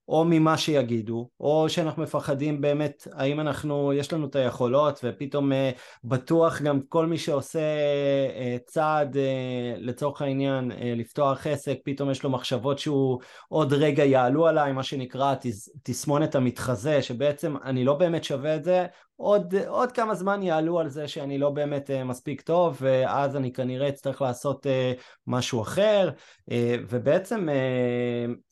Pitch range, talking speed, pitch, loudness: 130-155 Hz, 155 wpm, 140 Hz, -26 LUFS